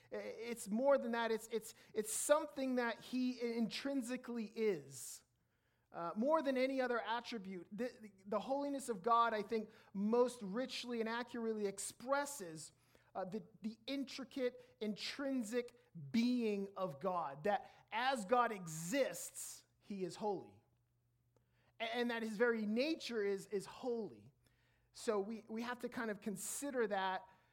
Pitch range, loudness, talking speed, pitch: 195-245 Hz, -41 LUFS, 140 wpm, 225 Hz